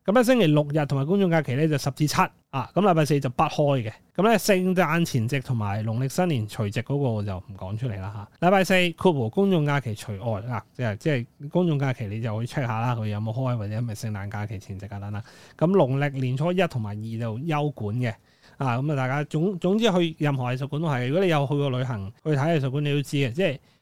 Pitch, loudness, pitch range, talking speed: 140 Hz, -25 LUFS, 115-160 Hz, 375 characters per minute